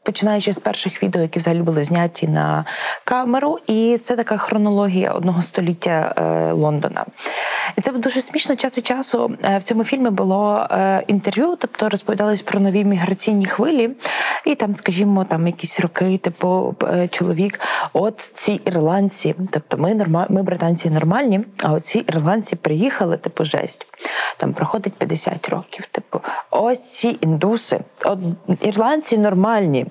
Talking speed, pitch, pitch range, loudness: 145 wpm, 200 Hz, 175-220 Hz, -19 LUFS